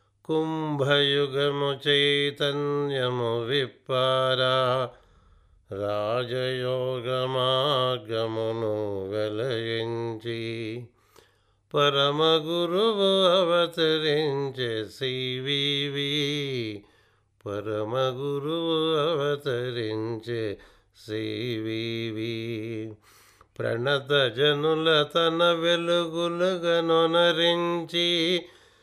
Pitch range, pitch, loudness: 115-155 Hz, 130 Hz, -25 LUFS